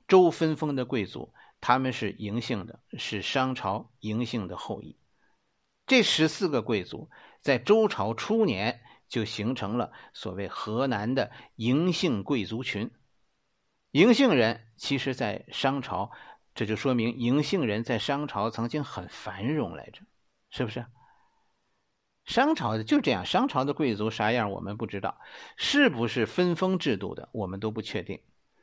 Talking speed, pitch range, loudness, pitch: 220 characters per minute, 110-155 Hz, -28 LUFS, 125 Hz